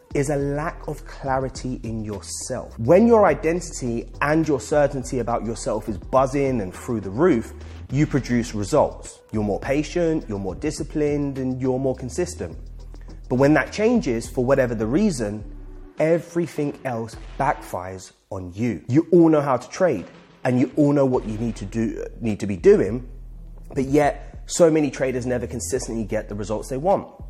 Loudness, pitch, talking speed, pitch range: -22 LUFS, 130 Hz, 170 wpm, 110-145 Hz